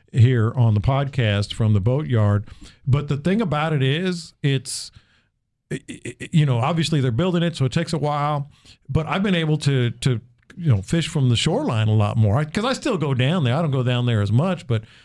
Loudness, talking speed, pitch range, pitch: -21 LUFS, 225 wpm, 120-160 Hz, 135 Hz